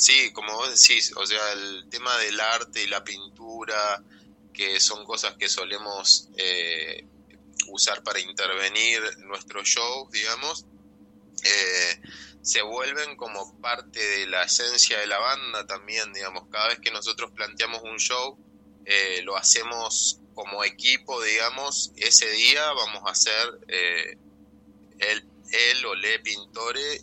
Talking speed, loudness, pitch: 140 wpm, -22 LUFS, 115 Hz